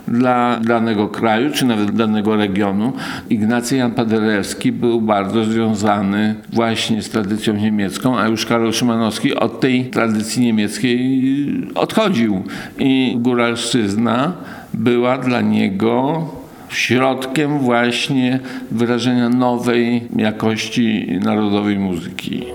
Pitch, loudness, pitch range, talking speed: 115 Hz, -17 LUFS, 110-125 Hz, 100 wpm